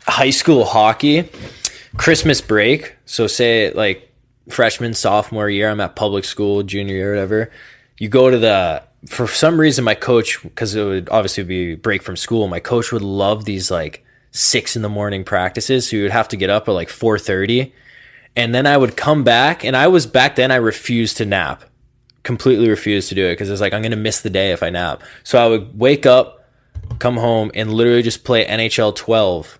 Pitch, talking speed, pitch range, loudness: 110 Hz, 205 wpm, 100-125 Hz, -16 LUFS